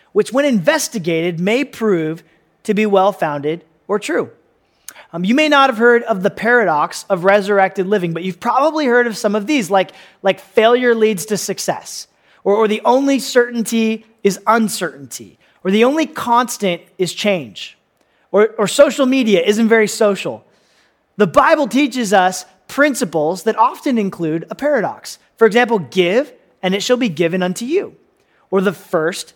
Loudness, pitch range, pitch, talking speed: -16 LUFS, 185-240 Hz, 210 Hz, 165 wpm